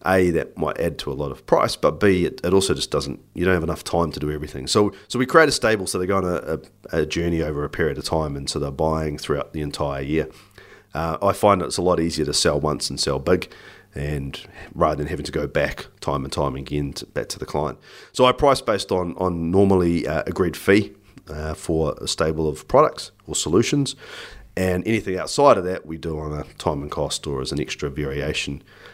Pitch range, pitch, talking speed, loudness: 75-95 Hz, 80 Hz, 240 wpm, -22 LUFS